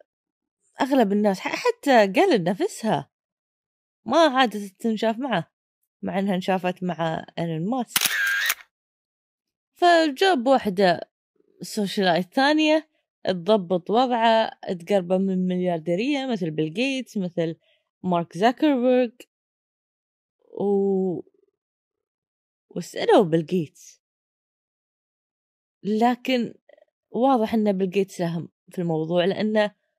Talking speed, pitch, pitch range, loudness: 80 wpm, 210 Hz, 180-270 Hz, -23 LUFS